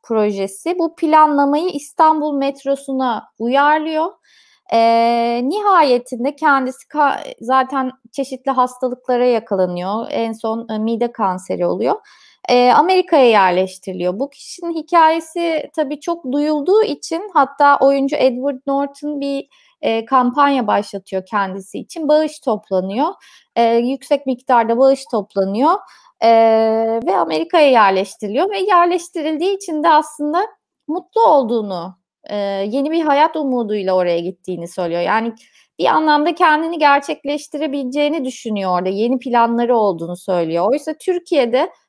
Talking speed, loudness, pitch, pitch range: 105 wpm, -16 LUFS, 275 Hz, 225-310 Hz